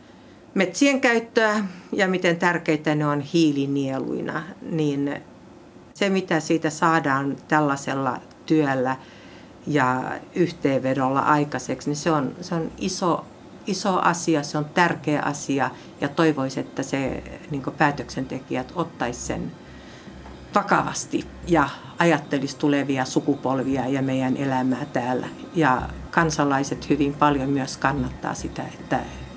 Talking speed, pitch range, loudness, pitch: 110 wpm, 135-165 Hz, -23 LUFS, 145 Hz